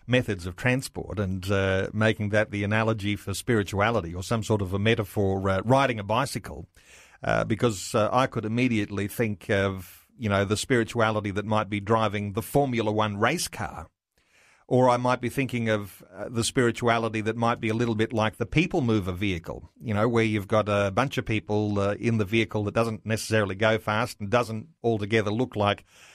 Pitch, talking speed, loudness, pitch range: 110 Hz, 195 wpm, -26 LUFS, 100-115 Hz